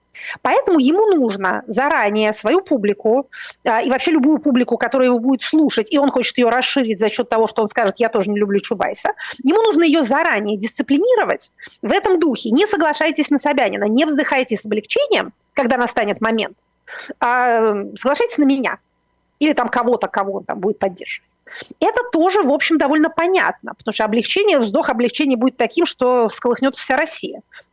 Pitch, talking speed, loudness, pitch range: 260 Hz, 170 wpm, -17 LUFS, 225-310 Hz